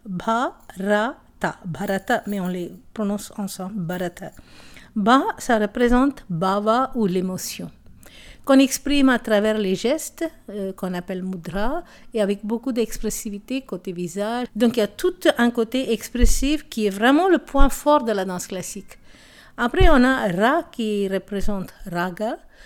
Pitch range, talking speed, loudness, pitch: 195-260 Hz, 145 wpm, -22 LUFS, 215 Hz